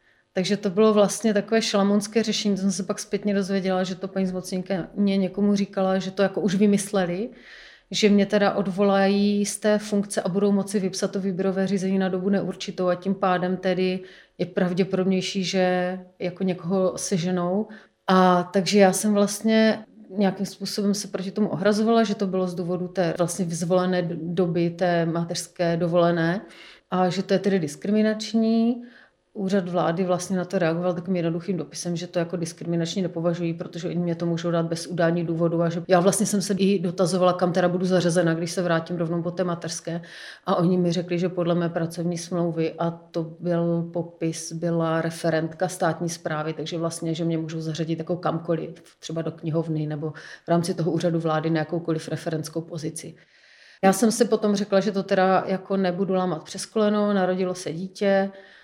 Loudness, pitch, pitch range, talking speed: -24 LUFS, 185 Hz, 170-195 Hz, 180 wpm